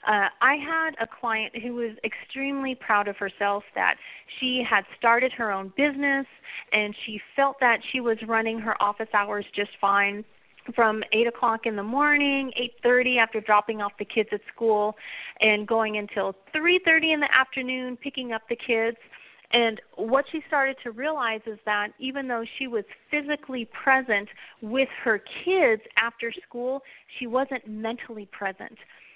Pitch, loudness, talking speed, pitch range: 230 Hz, -25 LUFS, 165 wpm, 215-265 Hz